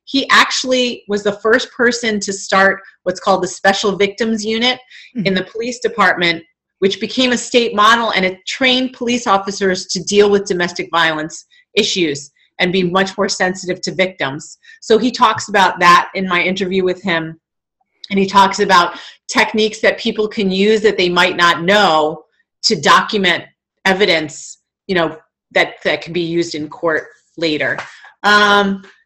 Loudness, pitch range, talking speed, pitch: -14 LUFS, 180-220 Hz, 165 wpm, 195 Hz